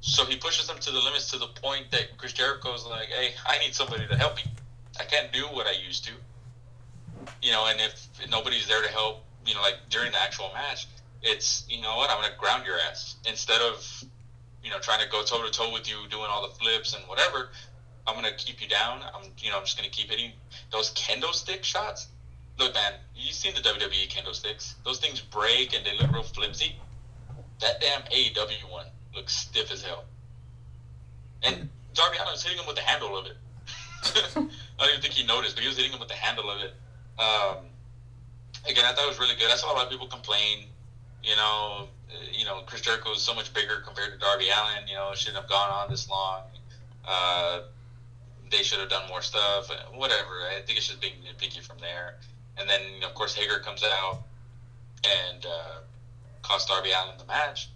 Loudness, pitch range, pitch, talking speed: -27 LUFS, 105-125 Hz, 120 Hz, 215 wpm